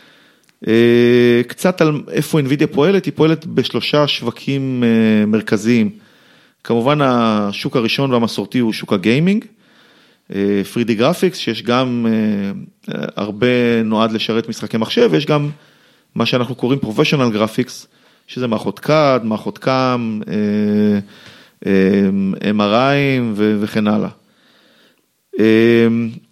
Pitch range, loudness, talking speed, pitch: 110-150 Hz, -16 LUFS, 95 wpm, 120 Hz